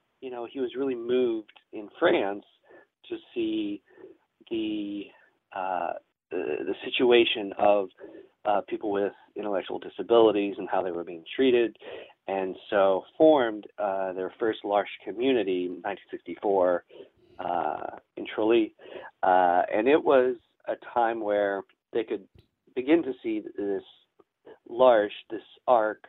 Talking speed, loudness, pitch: 130 wpm, -27 LUFS, 130 Hz